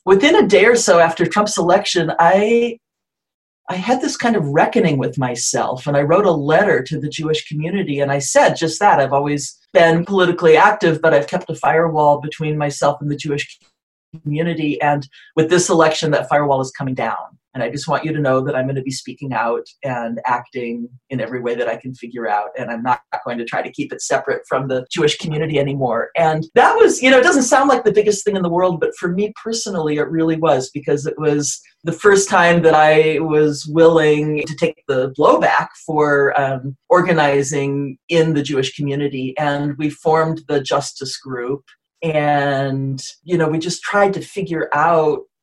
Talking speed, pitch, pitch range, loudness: 200 wpm, 150 Hz, 140-170 Hz, -16 LUFS